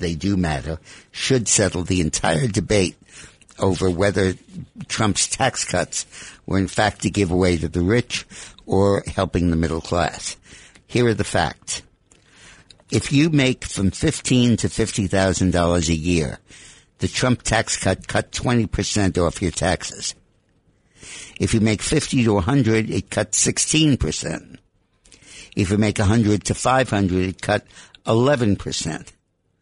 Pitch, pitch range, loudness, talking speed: 100 Hz, 90-115 Hz, -20 LUFS, 155 wpm